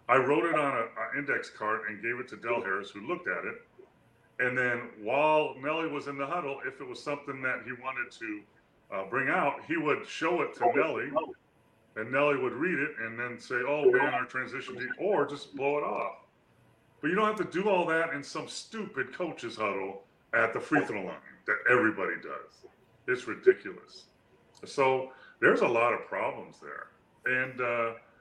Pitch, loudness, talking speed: 160 Hz, -30 LUFS, 195 wpm